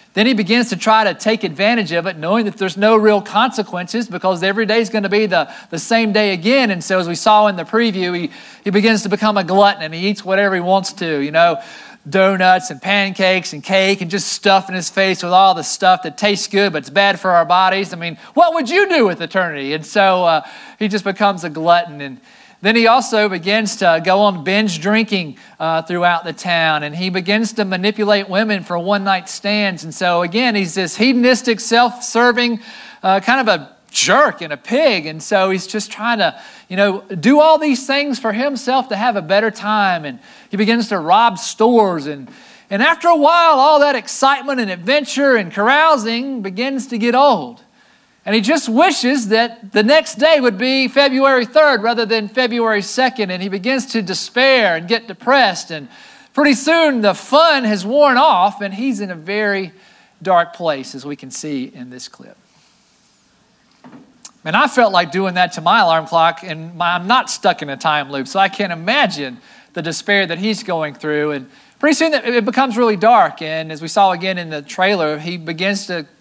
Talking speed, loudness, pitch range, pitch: 210 wpm, -15 LUFS, 180-240 Hz, 205 Hz